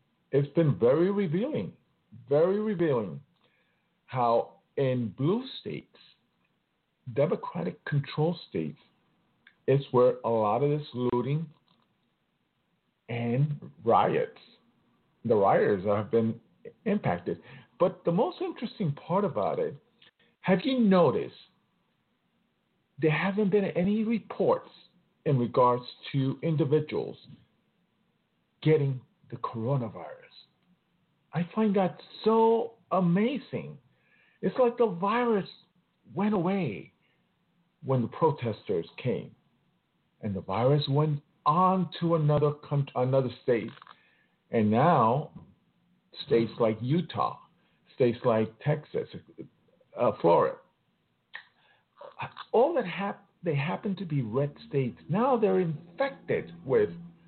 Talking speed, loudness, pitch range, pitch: 95 wpm, -28 LUFS, 135-200 Hz, 165 Hz